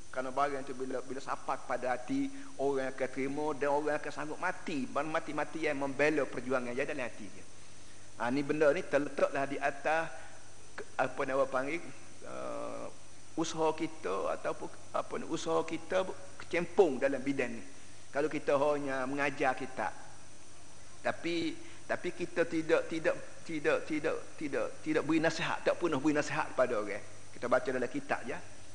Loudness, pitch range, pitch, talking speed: -34 LUFS, 130-165 Hz, 150 Hz, 150 wpm